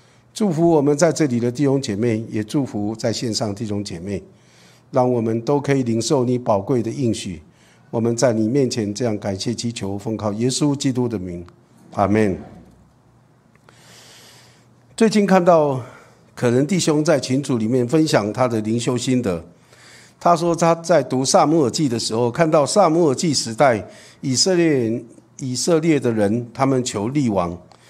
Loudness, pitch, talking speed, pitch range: -19 LUFS, 125 Hz, 240 characters per minute, 110-145 Hz